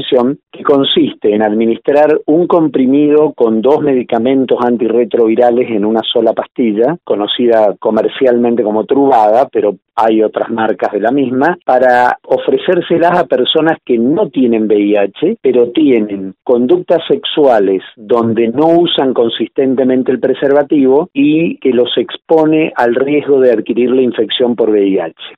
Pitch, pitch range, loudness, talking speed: 125 Hz, 115-150 Hz, -11 LUFS, 130 wpm